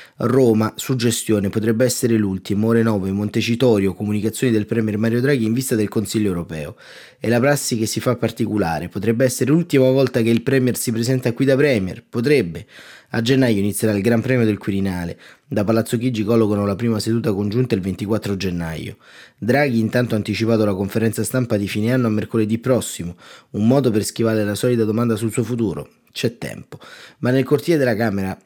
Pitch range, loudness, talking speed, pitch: 105-125 Hz, -19 LUFS, 185 wpm, 115 Hz